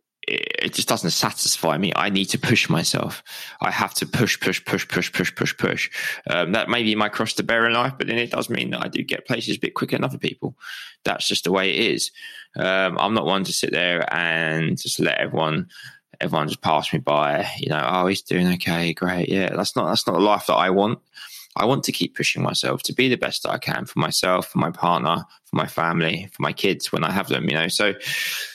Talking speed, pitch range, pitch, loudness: 245 wpm, 90-120 Hz, 95 Hz, -22 LUFS